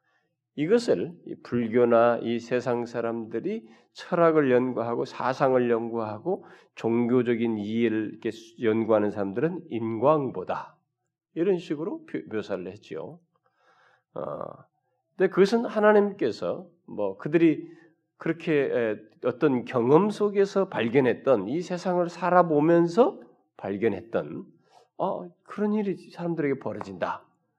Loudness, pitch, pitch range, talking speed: -26 LUFS, 150 Hz, 115-180 Hz, 250 characters per minute